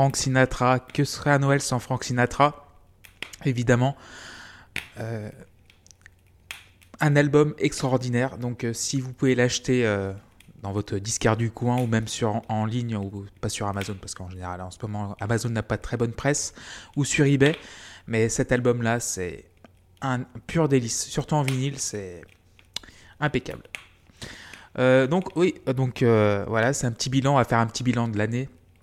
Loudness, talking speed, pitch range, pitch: -25 LUFS, 175 wpm, 100-130 Hz, 115 Hz